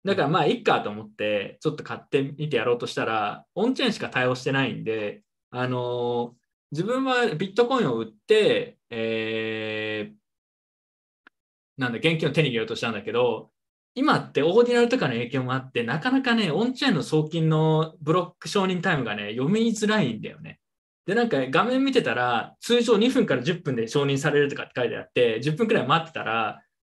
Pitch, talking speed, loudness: 155 Hz, 380 characters per minute, -24 LUFS